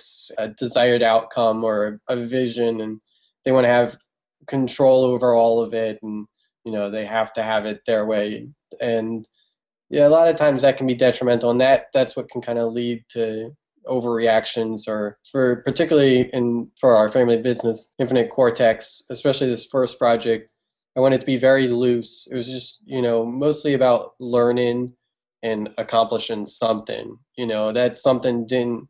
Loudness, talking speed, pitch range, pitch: -20 LUFS, 170 wpm, 115-130 Hz, 120 Hz